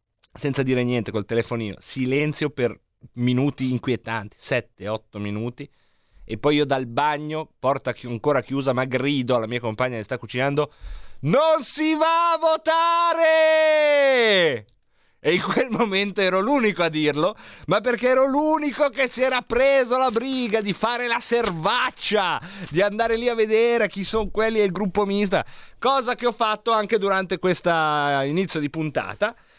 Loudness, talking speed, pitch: -22 LUFS, 160 wpm, 190 Hz